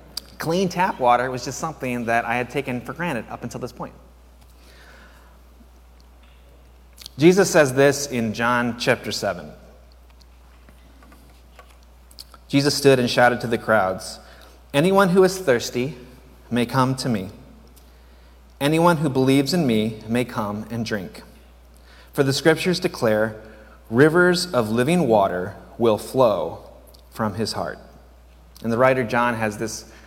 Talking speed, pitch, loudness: 130 wpm, 115 Hz, -21 LUFS